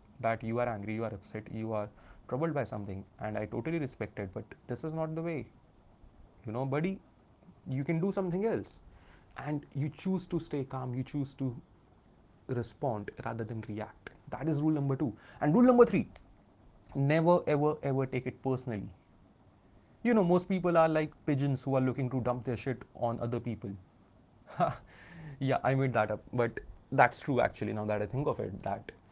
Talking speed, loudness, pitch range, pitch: 190 wpm, -33 LUFS, 105-150 Hz, 125 Hz